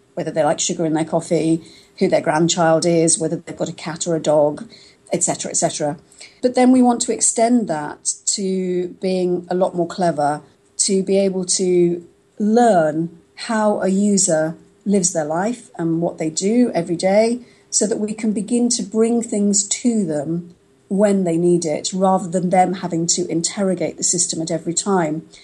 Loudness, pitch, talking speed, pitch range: -18 LUFS, 180 Hz, 185 wpm, 165-205 Hz